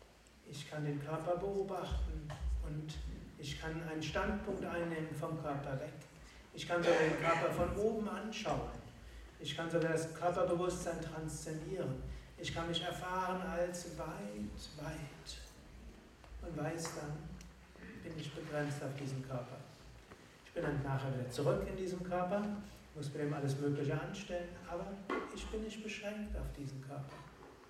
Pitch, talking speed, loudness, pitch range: 160 Hz, 145 wpm, -40 LUFS, 145-175 Hz